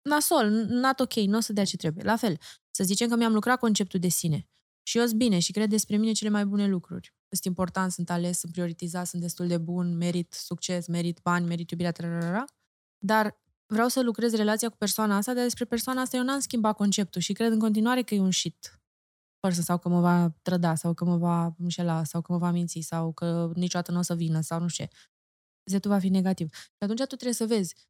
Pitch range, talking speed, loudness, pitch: 175-220 Hz, 230 wpm, -27 LUFS, 185 Hz